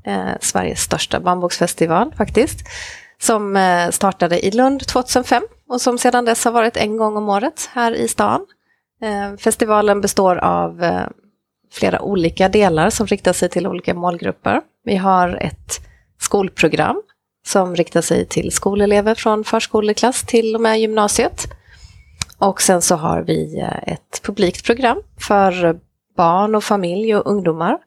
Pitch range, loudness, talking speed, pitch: 180-230 Hz, -17 LUFS, 135 wpm, 205 Hz